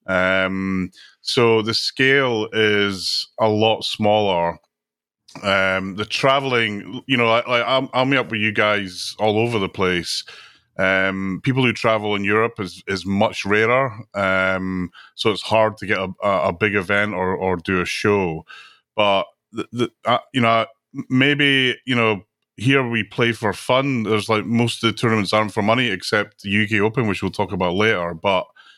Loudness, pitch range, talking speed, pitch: -19 LUFS, 95-115 Hz, 175 wpm, 110 Hz